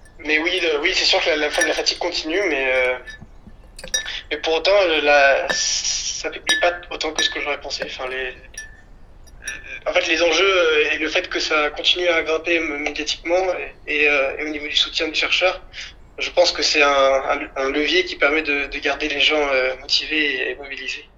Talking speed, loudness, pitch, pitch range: 205 wpm, -19 LUFS, 150 Hz, 140-170 Hz